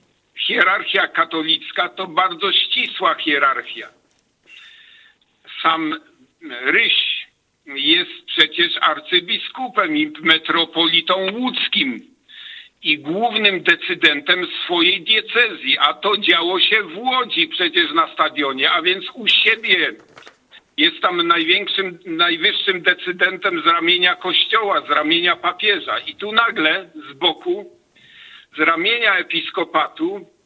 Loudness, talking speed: -16 LUFS, 100 wpm